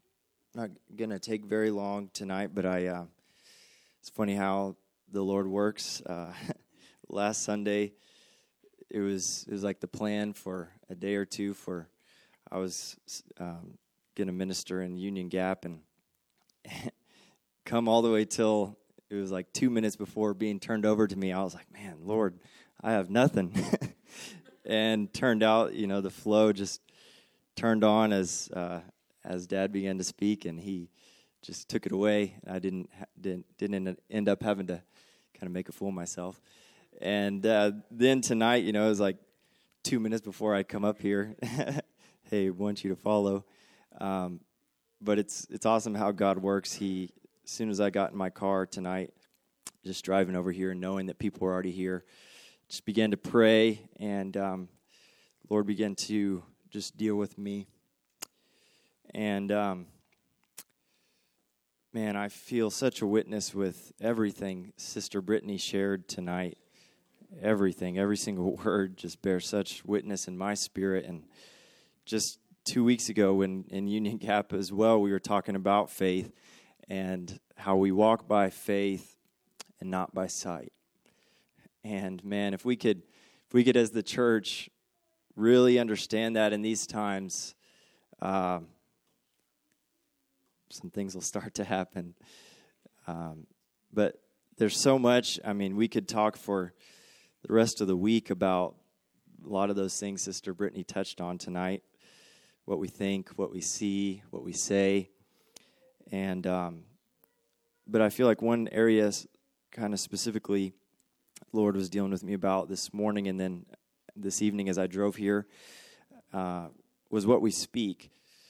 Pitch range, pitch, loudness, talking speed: 95-105 Hz, 100 Hz, -31 LUFS, 160 wpm